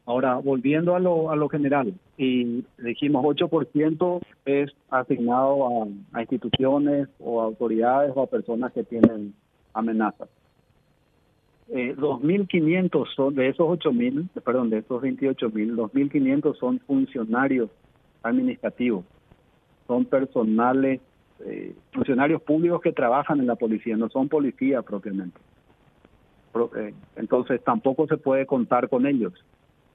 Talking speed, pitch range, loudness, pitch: 110 wpm, 120-155 Hz, -24 LUFS, 135 Hz